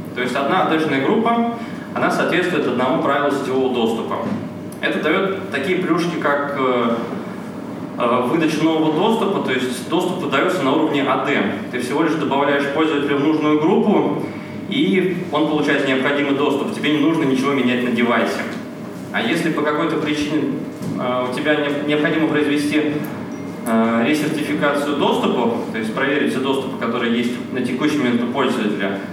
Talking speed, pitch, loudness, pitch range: 140 wpm, 150 Hz, -19 LUFS, 135-155 Hz